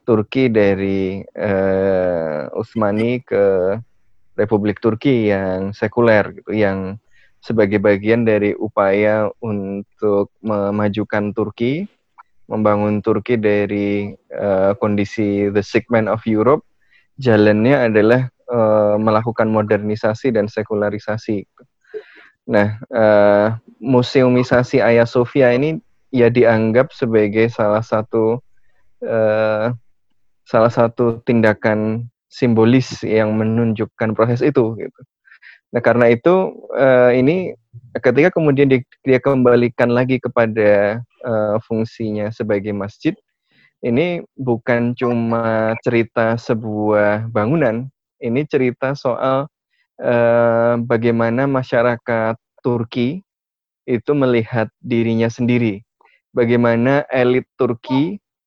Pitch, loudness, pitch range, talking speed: 115 Hz, -17 LUFS, 105-125 Hz, 85 wpm